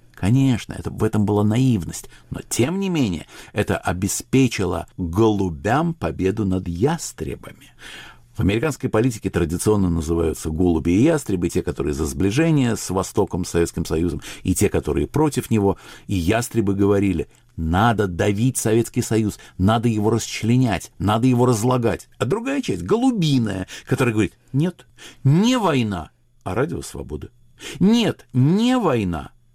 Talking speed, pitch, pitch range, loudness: 135 wpm, 110 Hz, 90-130 Hz, -21 LUFS